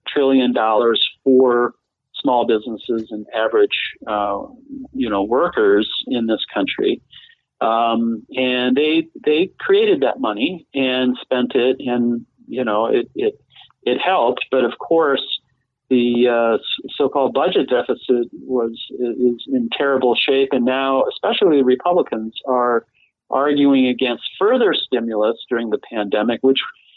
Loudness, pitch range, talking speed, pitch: -18 LUFS, 120-150 Hz, 125 wpm, 130 Hz